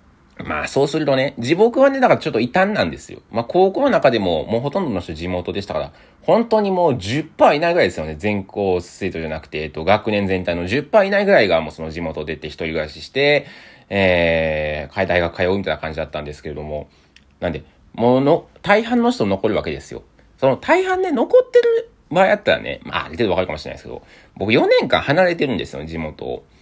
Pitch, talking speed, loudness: 100 Hz, 435 characters per minute, -18 LUFS